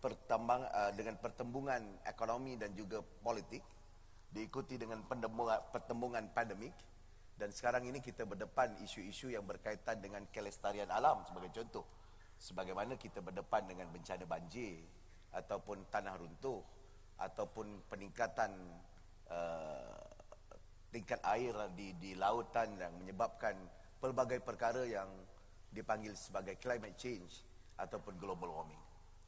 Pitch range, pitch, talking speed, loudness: 90-120 Hz, 100 Hz, 110 wpm, -43 LUFS